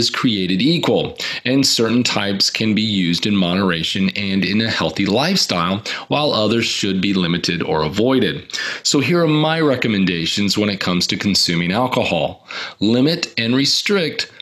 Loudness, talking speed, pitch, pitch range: -17 LUFS, 150 wpm, 100 Hz, 95-120 Hz